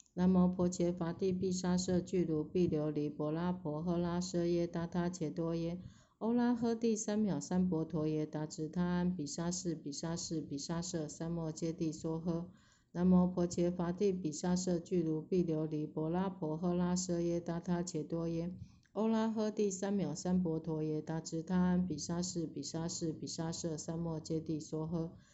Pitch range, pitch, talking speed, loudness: 160-180 Hz, 170 Hz, 260 characters per minute, -36 LUFS